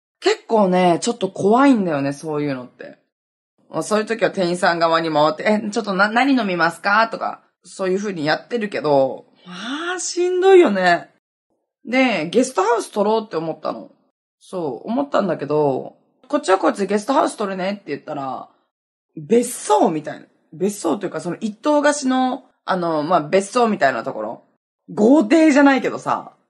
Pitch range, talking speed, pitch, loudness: 165-255 Hz, 360 characters per minute, 205 Hz, -18 LUFS